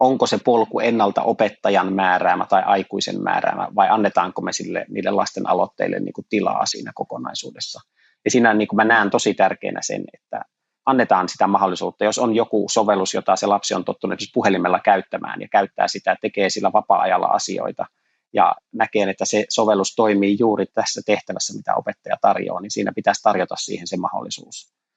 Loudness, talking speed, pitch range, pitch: -20 LUFS, 170 wpm, 100-110 Hz, 105 Hz